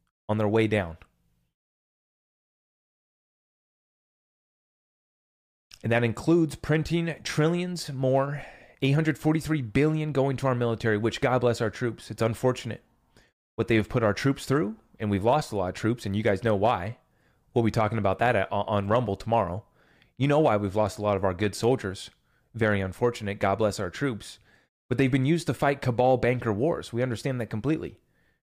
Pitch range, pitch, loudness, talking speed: 105-135 Hz, 115 Hz, -26 LUFS, 170 wpm